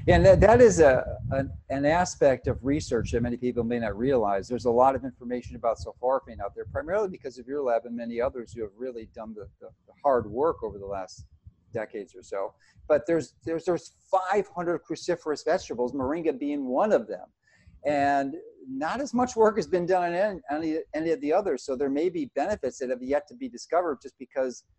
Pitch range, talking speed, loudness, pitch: 120-185 Hz, 210 wpm, -26 LUFS, 145 Hz